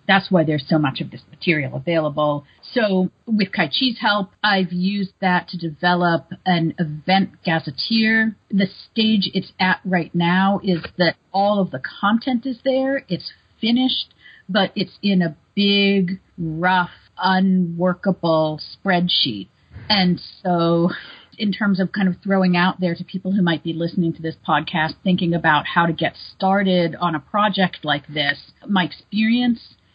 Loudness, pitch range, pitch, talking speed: -20 LUFS, 170-200 Hz, 185 Hz, 155 wpm